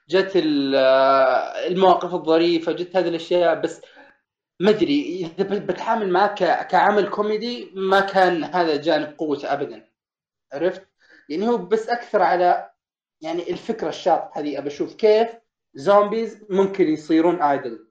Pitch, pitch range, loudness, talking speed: 180 Hz, 160-205 Hz, -20 LUFS, 120 wpm